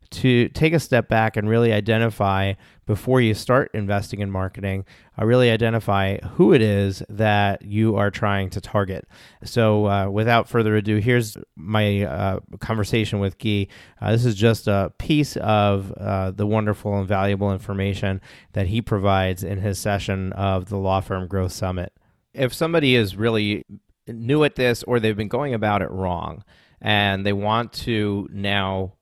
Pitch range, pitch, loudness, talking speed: 100-115 Hz, 105 Hz, -21 LUFS, 165 wpm